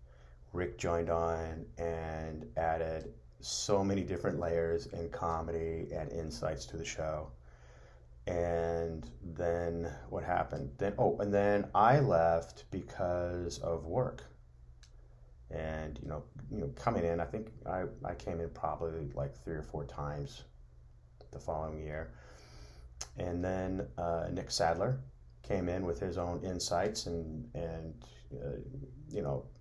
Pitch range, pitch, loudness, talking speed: 65-85 Hz, 80 Hz, -36 LUFS, 135 wpm